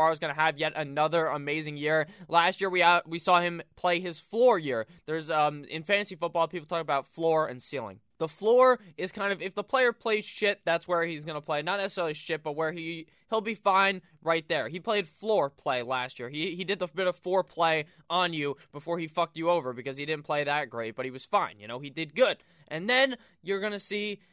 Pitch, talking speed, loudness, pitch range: 170 Hz, 240 wpm, -28 LUFS, 155-190 Hz